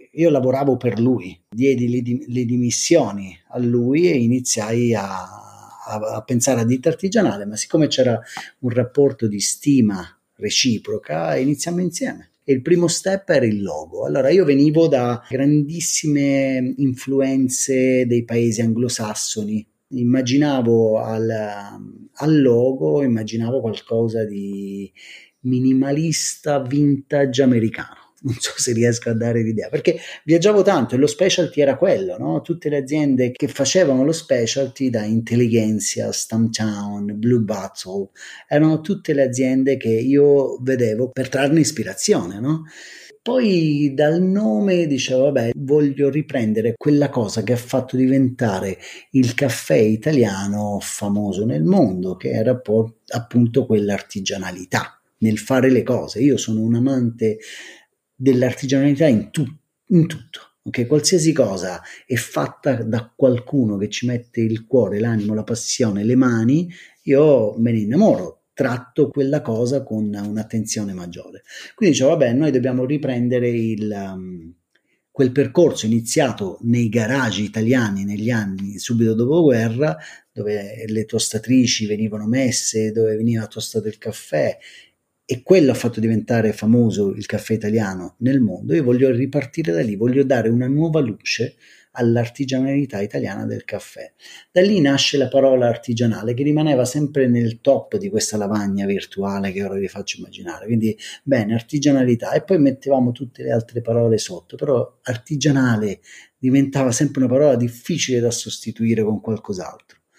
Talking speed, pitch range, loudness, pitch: 135 wpm, 110-140 Hz, -19 LUFS, 125 Hz